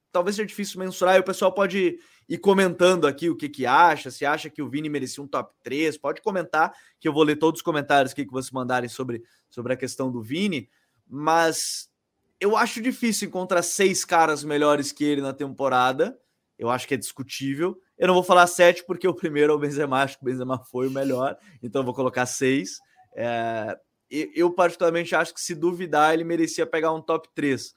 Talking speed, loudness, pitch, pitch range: 205 wpm, -23 LUFS, 155 Hz, 135-180 Hz